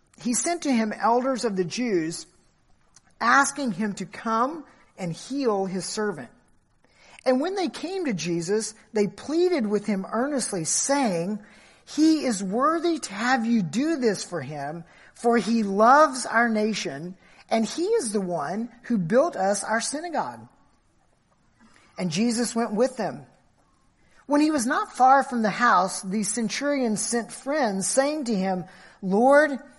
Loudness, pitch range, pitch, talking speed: -24 LUFS, 200-275 Hz, 230 Hz, 150 wpm